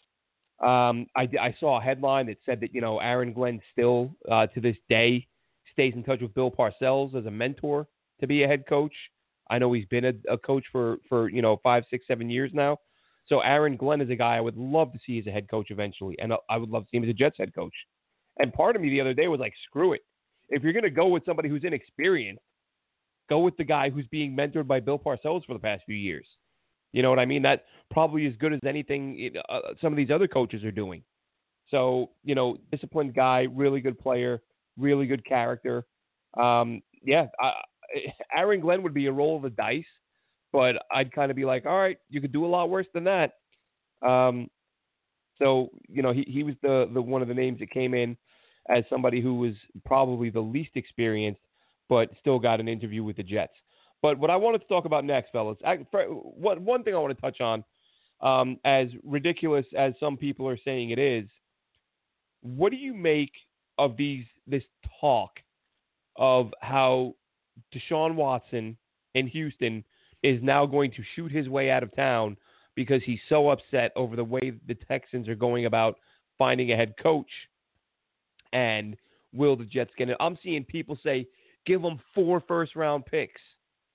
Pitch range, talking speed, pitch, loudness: 120-145 Hz, 205 wpm, 130 Hz, -27 LUFS